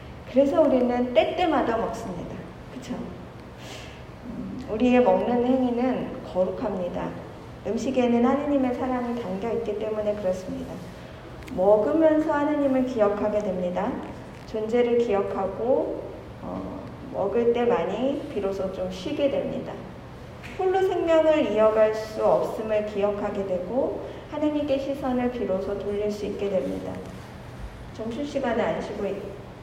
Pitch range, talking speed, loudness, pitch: 205-270 Hz, 270 characters per minute, -25 LUFS, 235 Hz